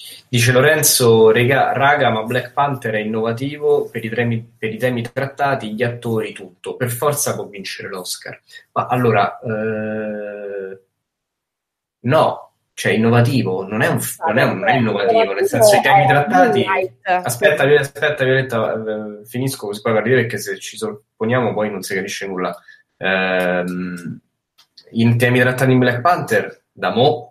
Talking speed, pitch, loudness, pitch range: 145 wpm, 120 Hz, -17 LUFS, 110-140 Hz